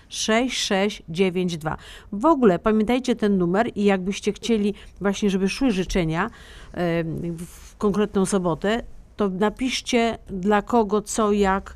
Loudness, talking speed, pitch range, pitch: -22 LUFS, 115 wpm, 190-220 Hz, 205 Hz